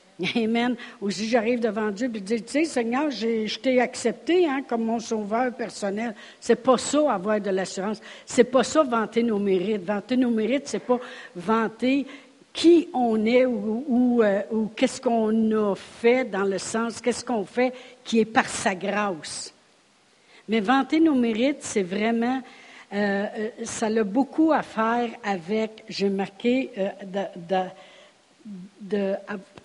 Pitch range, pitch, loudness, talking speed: 205-250 Hz, 230 Hz, -24 LUFS, 170 wpm